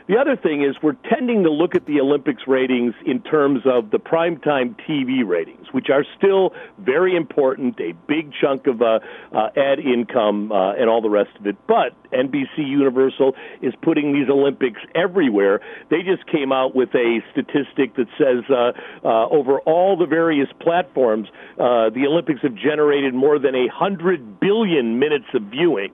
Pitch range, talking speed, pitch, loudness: 125-170 Hz, 175 wpm, 140 Hz, -19 LUFS